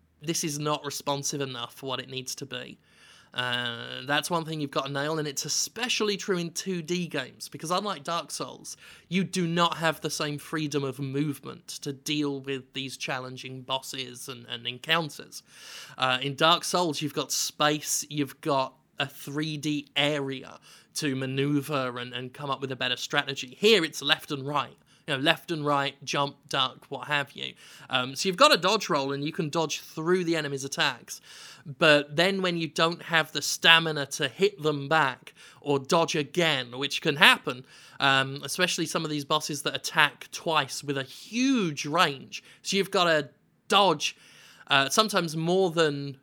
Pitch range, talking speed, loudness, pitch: 135-165 Hz, 180 wpm, -27 LUFS, 150 Hz